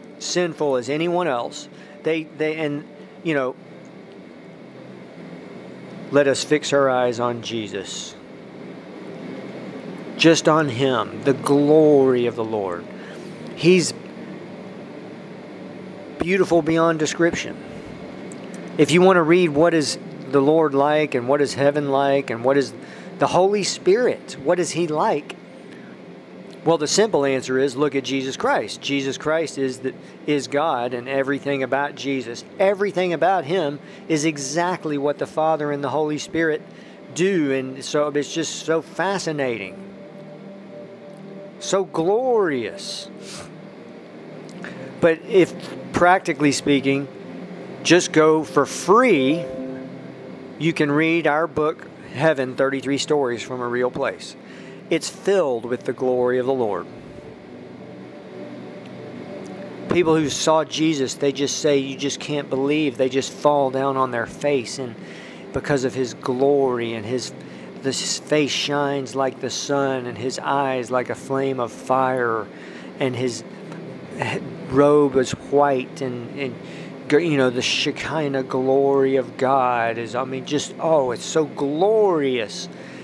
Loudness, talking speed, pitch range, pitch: -21 LUFS, 130 wpm, 135-165 Hz, 145 Hz